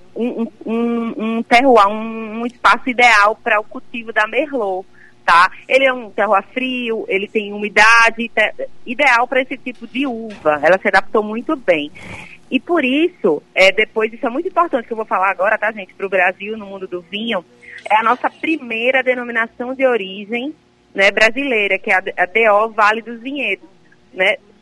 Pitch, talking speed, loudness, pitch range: 225 Hz, 185 wpm, -15 LUFS, 205-255 Hz